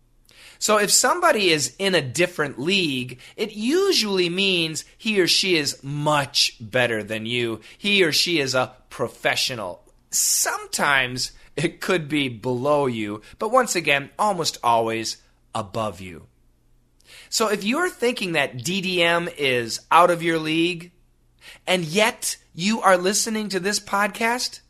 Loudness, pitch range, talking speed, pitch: -21 LUFS, 125-200 Hz, 140 wpm, 165 Hz